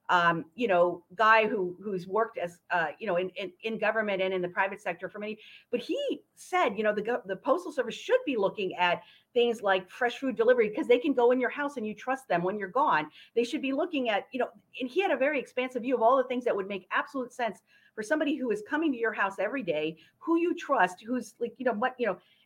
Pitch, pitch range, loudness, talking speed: 225 Hz, 190-260 Hz, -29 LUFS, 260 wpm